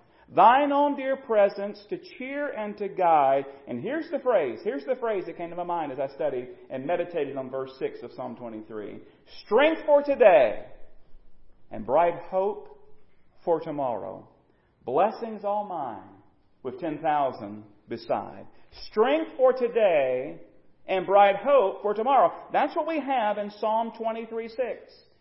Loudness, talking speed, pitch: -25 LUFS, 150 wpm, 210 Hz